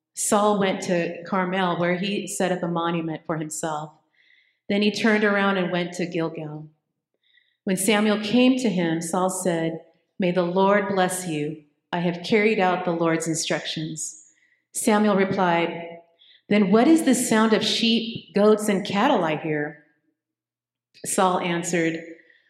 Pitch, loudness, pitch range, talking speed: 180 Hz, -22 LUFS, 165-205 Hz, 145 wpm